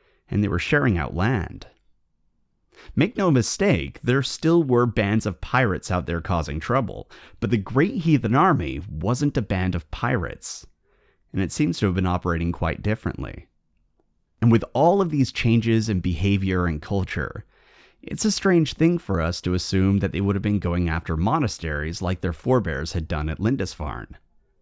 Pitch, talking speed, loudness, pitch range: 95 Hz, 175 wpm, -23 LUFS, 85-120 Hz